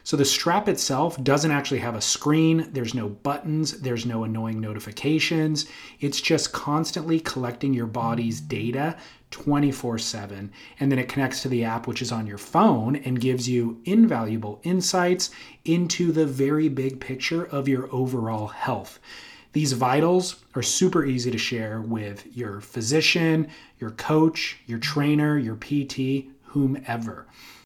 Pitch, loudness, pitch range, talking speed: 135 Hz, -24 LUFS, 120-155 Hz, 145 wpm